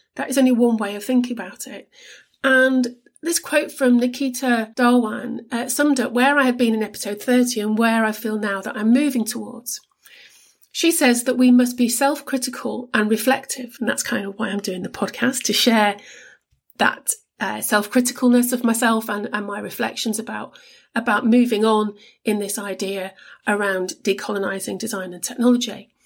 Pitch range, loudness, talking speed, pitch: 210-255 Hz, -20 LUFS, 175 wpm, 240 Hz